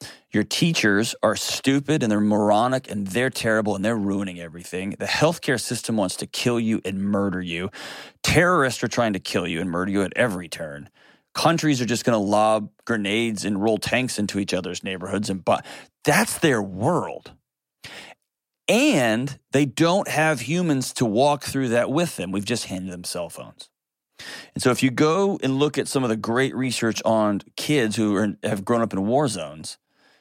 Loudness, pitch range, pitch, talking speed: -22 LUFS, 100-130 Hz, 110 Hz, 190 wpm